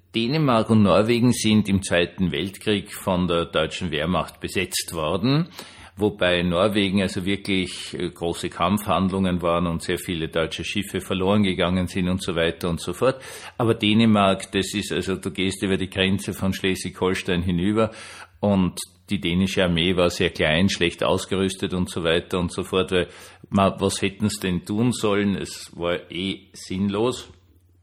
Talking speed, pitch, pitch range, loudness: 155 wpm, 95 Hz, 90-100 Hz, -23 LUFS